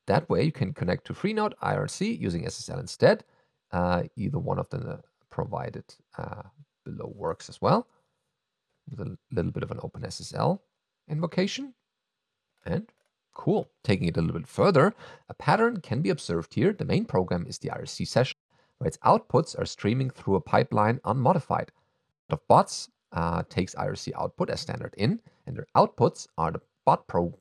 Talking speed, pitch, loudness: 170 wpm, 130 Hz, -27 LUFS